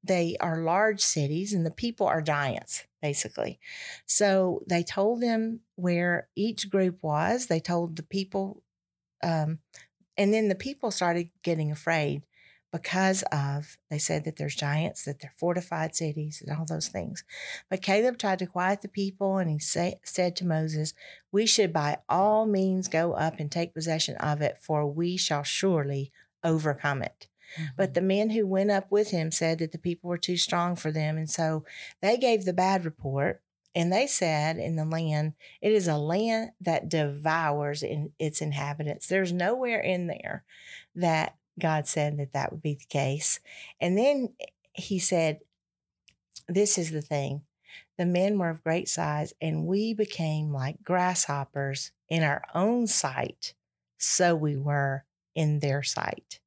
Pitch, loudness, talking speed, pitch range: 170 Hz, -27 LUFS, 165 wpm, 150-190 Hz